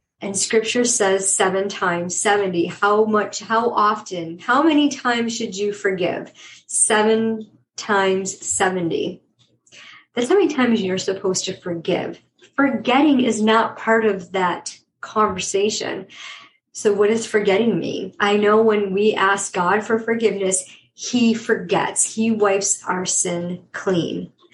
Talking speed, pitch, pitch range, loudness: 130 wpm, 210 Hz, 190-225 Hz, -19 LUFS